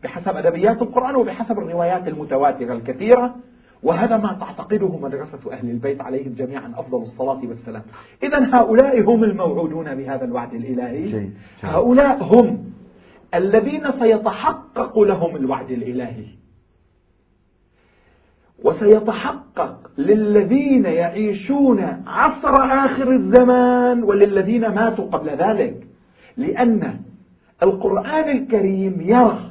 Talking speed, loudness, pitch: 95 wpm, -18 LUFS, 205 Hz